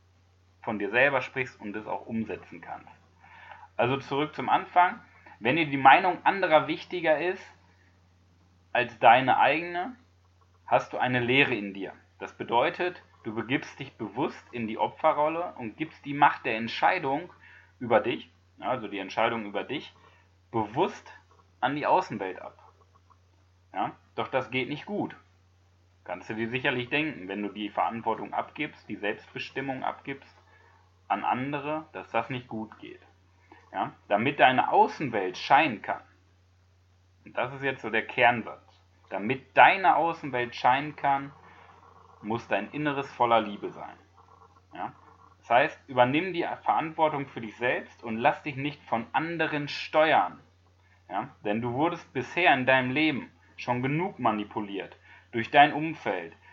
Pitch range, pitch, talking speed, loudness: 90-145 Hz, 115 Hz, 145 wpm, -27 LUFS